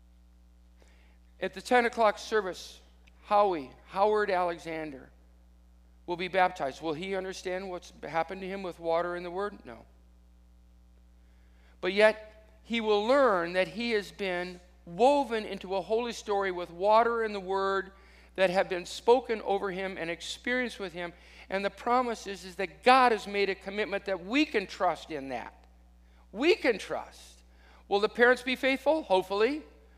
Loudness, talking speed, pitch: -29 LUFS, 160 wpm, 190 Hz